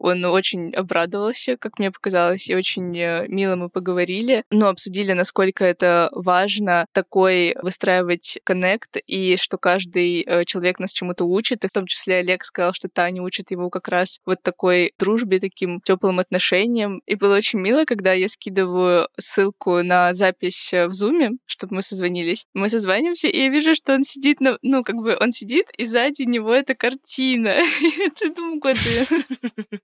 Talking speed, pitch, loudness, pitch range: 160 wpm, 190 Hz, -20 LUFS, 180-235 Hz